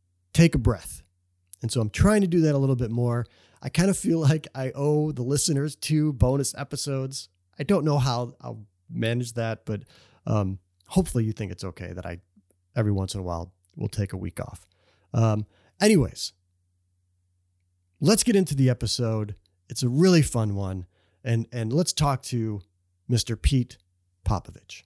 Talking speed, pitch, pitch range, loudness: 175 wpm, 115 Hz, 90-135 Hz, -25 LUFS